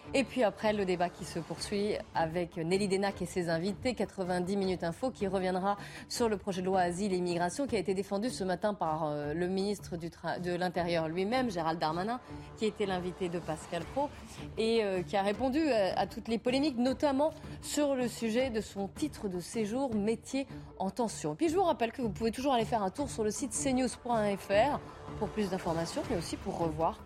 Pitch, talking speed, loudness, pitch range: 200 Hz, 205 wpm, -33 LUFS, 180-235 Hz